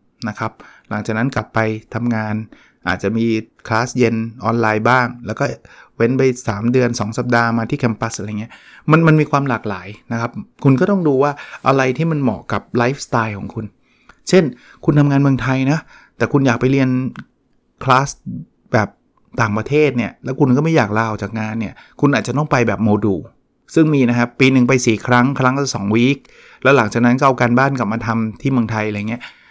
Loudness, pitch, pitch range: -17 LUFS, 120 Hz, 110-135 Hz